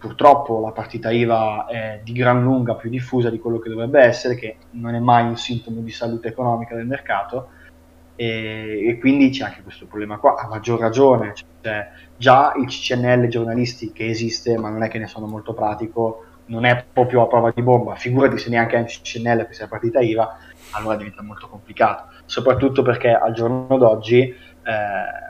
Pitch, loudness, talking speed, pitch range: 115 Hz, -19 LUFS, 185 wpm, 110-120 Hz